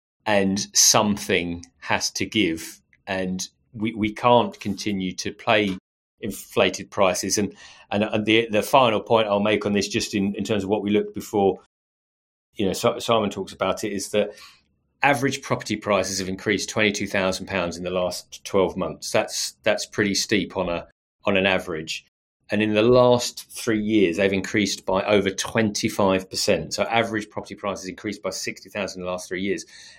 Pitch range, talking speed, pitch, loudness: 95-110 Hz, 190 wpm, 100 Hz, -23 LUFS